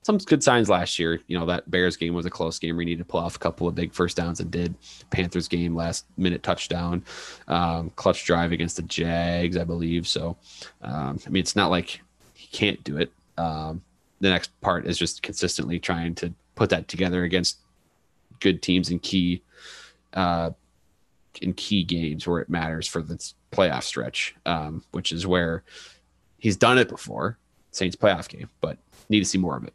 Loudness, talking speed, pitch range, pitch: -25 LUFS, 195 wpm, 85-90 Hz, 85 Hz